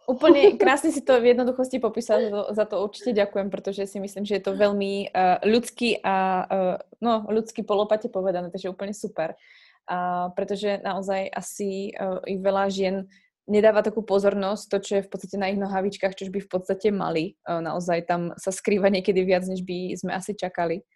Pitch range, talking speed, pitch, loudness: 190-210 Hz, 180 wpm, 195 Hz, -24 LUFS